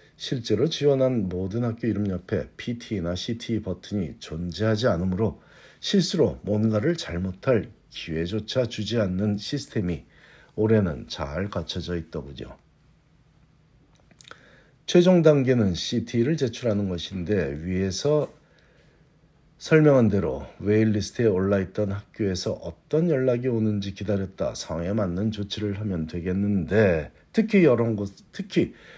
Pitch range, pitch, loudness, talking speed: 95-125 Hz, 105 Hz, -25 LUFS, 275 characters per minute